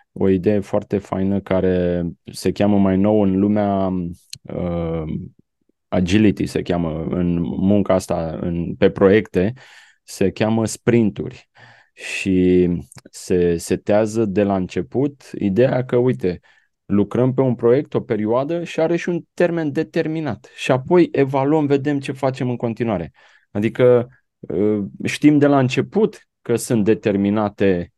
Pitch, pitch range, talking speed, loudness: 105 Hz, 95-130 Hz, 135 wpm, -19 LUFS